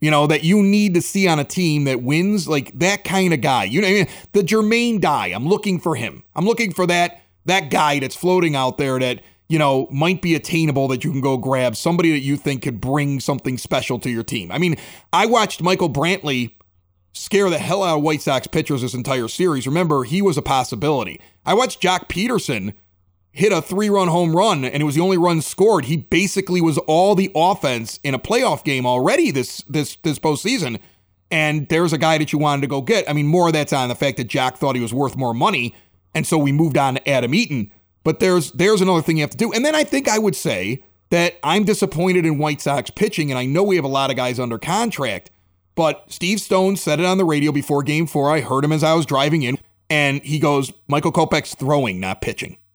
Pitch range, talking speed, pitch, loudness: 135-180 Hz, 235 wpm, 150 Hz, -18 LUFS